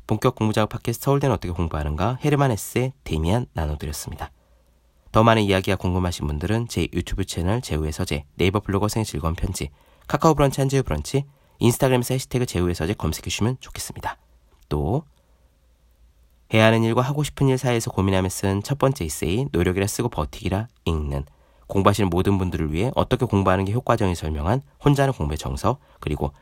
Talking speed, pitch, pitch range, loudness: 440 characters per minute, 95 Hz, 80-120 Hz, -23 LUFS